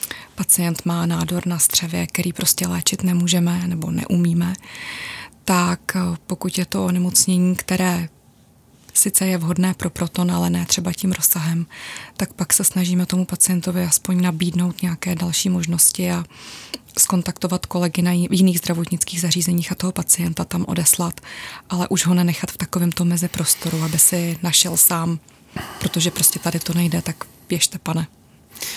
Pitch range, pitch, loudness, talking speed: 170-180 Hz, 175 Hz, -18 LUFS, 145 wpm